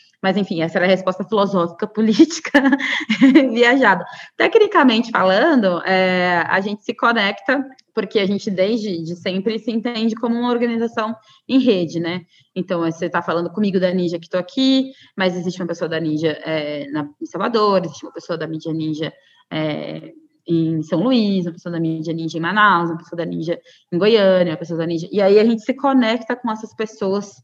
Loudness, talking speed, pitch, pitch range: -18 LUFS, 190 wpm, 190 Hz, 170-230 Hz